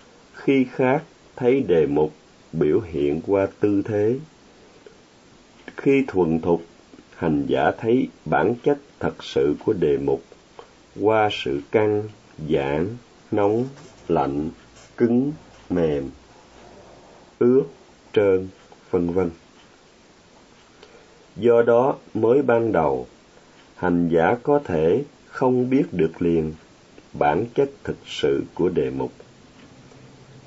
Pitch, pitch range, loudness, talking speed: 105 Hz, 85-130 Hz, -22 LUFS, 110 wpm